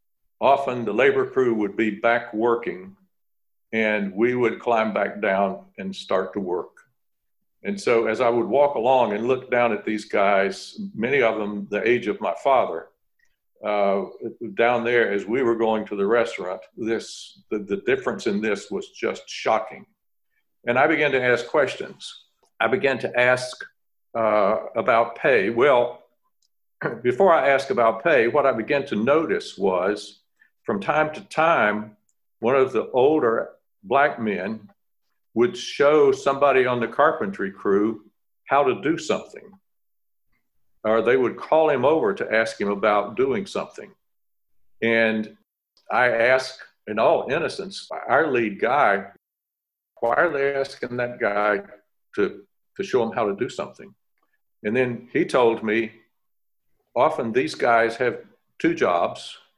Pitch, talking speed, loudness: 120 Hz, 150 wpm, -22 LUFS